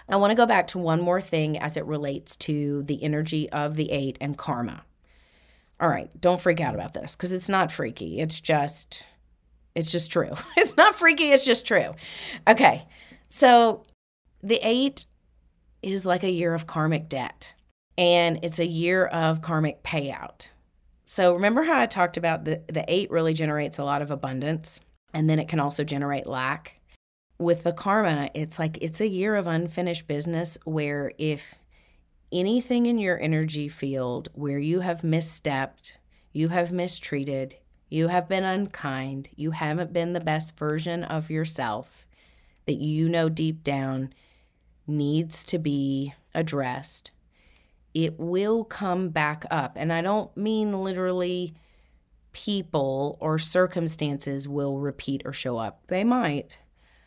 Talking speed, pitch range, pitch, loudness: 155 wpm, 140-175 Hz, 160 Hz, -25 LUFS